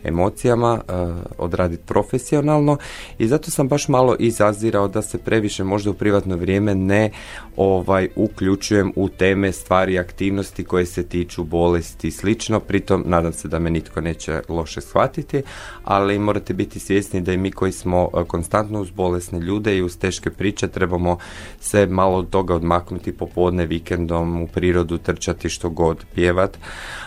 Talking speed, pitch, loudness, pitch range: 155 wpm, 95 Hz, -20 LUFS, 85-105 Hz